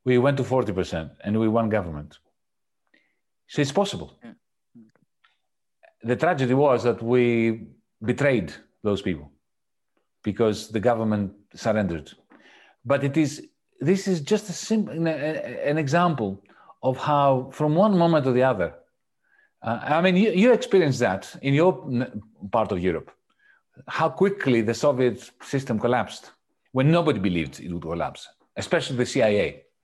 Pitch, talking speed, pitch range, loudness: 130 Hz, 135 wpm, 110-160 Hz, -23 LUFS